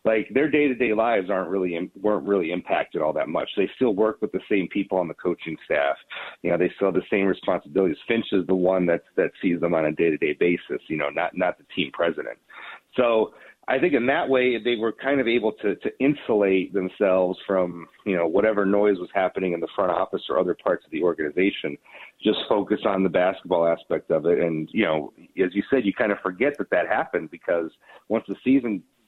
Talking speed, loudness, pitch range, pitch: 230 wpm, -24 LUFS, 90-110 Hz, 95 Hz